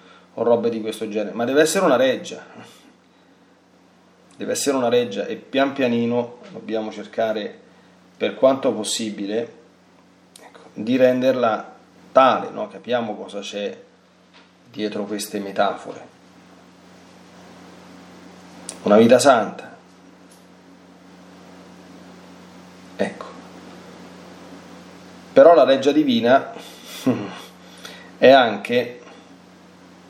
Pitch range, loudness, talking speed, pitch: 90-120 Hz, -19 LUFS, 85 wpm, 100 Hz